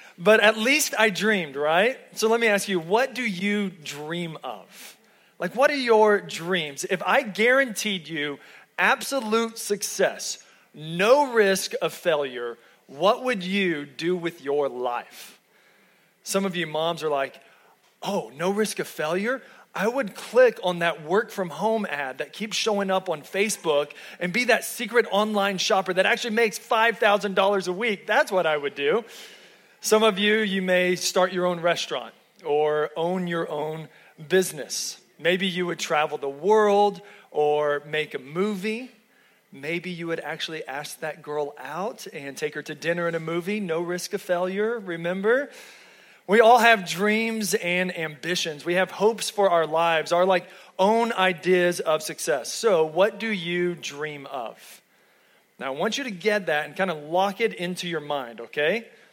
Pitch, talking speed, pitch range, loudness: 185 Hz, 170 wpm, 165-215 Hz, -24 LUFS